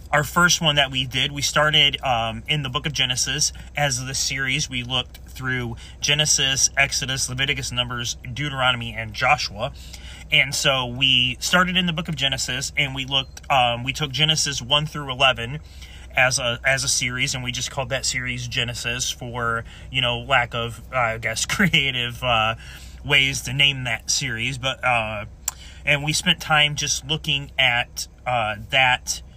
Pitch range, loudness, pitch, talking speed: 120-145 Hz, -20 LUFS, 130 Hz, 170 wpm